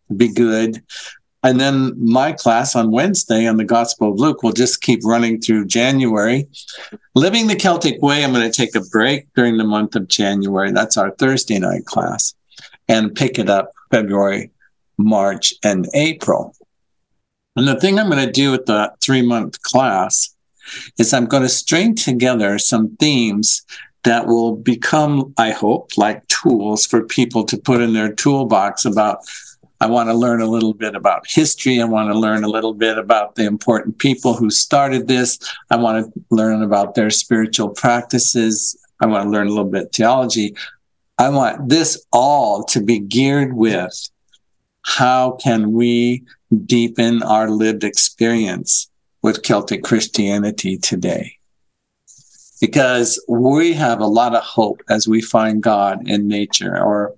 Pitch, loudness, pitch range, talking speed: 115 Hz, -16 LUFS, 110-130 Hz, 165 wpm